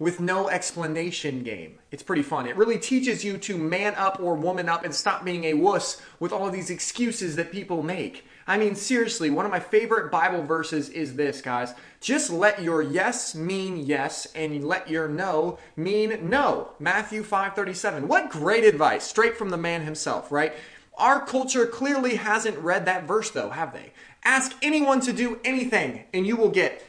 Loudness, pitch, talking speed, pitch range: -25 LUFS, 185 Hz, 185 wpm, 165-220 Hz